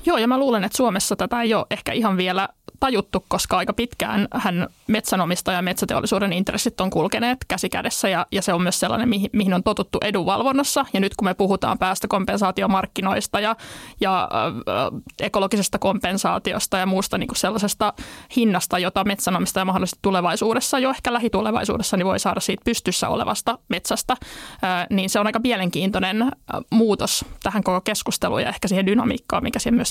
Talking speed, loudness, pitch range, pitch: 170 wpm, -21 LUFS, 190-230 Hz, 205 Hz